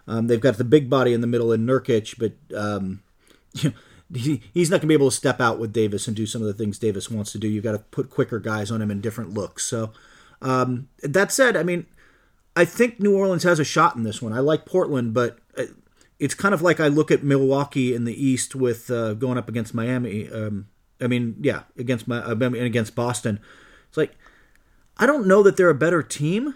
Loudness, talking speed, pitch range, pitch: -22 LUFS, 235 wpm, 110-145 Hz, 125 Hz